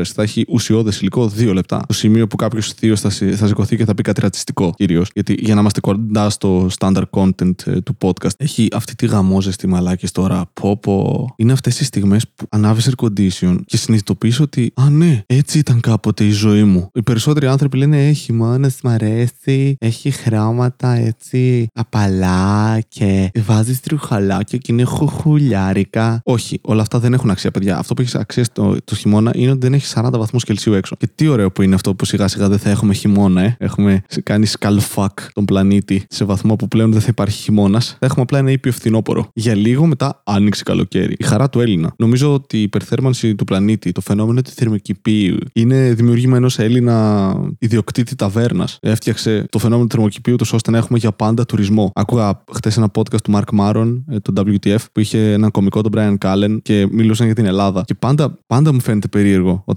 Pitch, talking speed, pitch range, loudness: 110 Hz, 195 wpm, 100-125 Hz, -15 LUFS